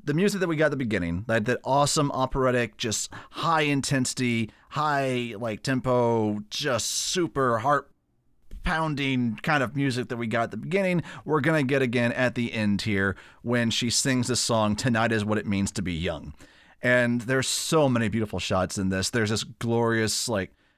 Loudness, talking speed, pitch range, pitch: -25 LUFS, 190 wpm, 110-140 Hz, 120 Hz